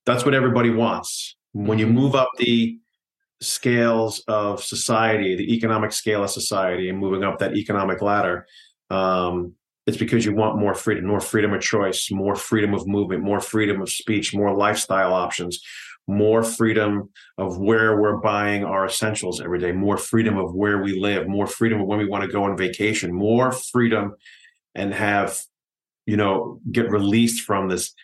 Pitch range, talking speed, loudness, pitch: 95-115 Hz, 175 wpm, -21 LUFS, 105 Hz